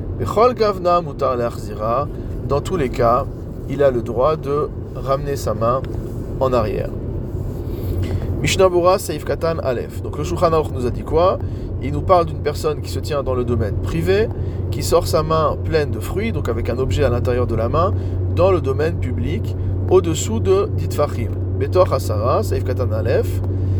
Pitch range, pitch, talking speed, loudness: 95-120 Hz, 105 Hz, 165 wpm, -19 LUFS